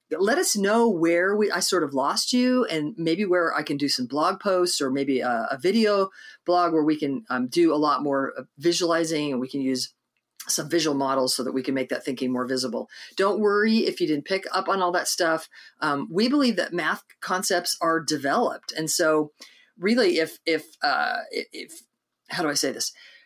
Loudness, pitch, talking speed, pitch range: -24 LUFS, 165 Hz, 210 wpm, 140-195 Hz